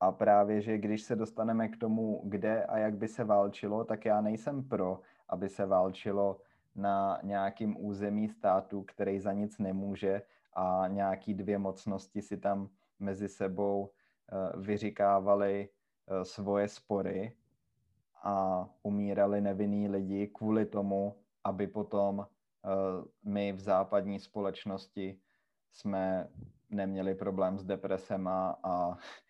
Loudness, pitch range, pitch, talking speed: -34 LUFS, 95-105 Hz, 100 Hz, 120 wpm